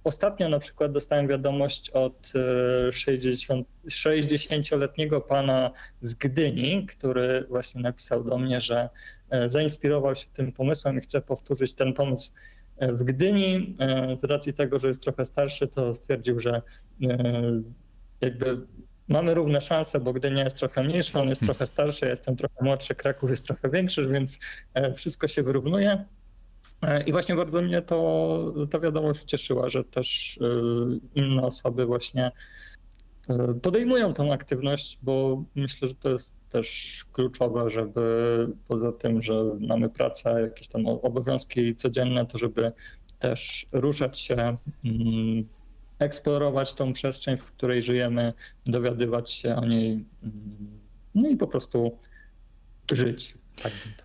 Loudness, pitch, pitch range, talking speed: -27 LUFS, 130 Hz, 120-145 Hz, 130 wpm